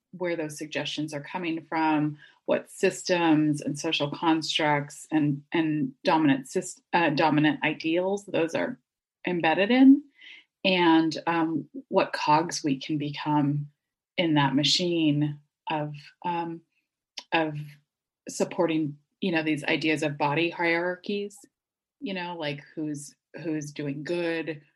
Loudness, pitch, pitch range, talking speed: -26 LUFS, 160 Hz, 150-175 Hz, 120 wpm